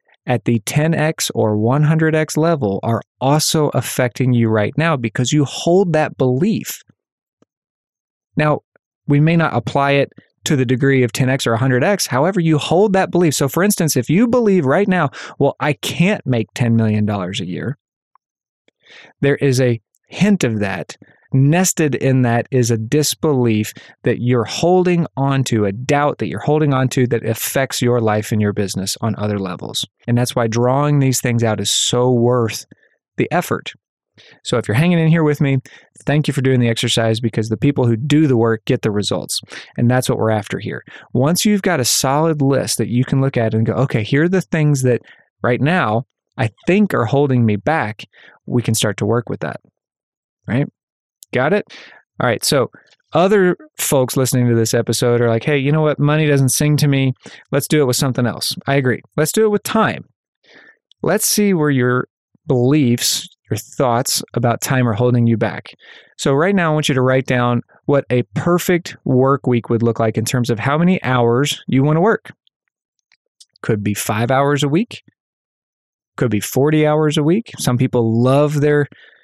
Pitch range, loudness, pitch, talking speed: 120-155 Hz, -16 LUFS, 135 Hz, 190 wpm